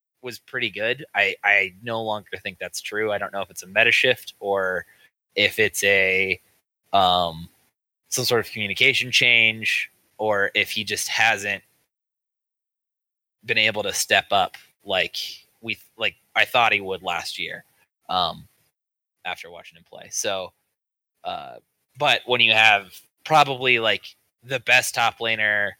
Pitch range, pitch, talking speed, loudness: 95-120 Hz, 105 Hz, 150 wpm, -21 LUFS